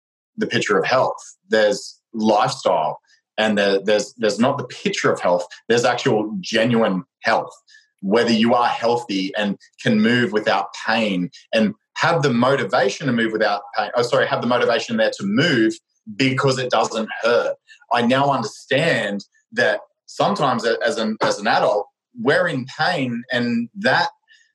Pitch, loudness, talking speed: 120 Hz, -19 LUFS, 155 wpm